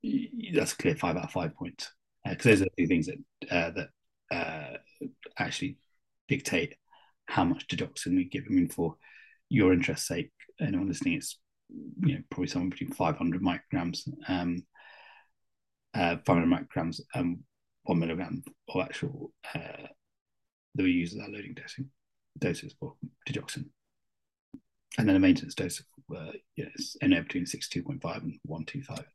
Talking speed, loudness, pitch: 160 wpm, -31 LUFS, 250 Hz